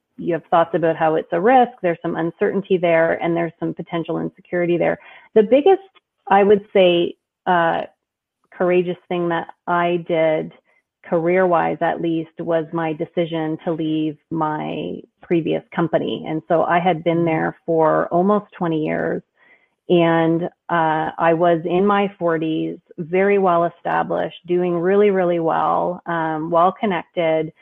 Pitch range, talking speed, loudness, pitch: 165-180 Hz, 150 wpm, -19 LUFS, 170 Hz